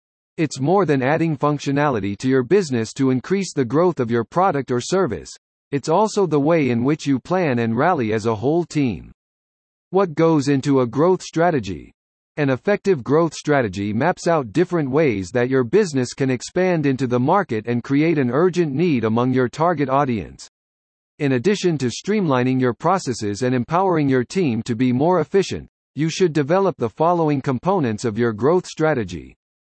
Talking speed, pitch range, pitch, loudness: 175 wpm, 120-170 Hz, 140 Hz, -19 LUFS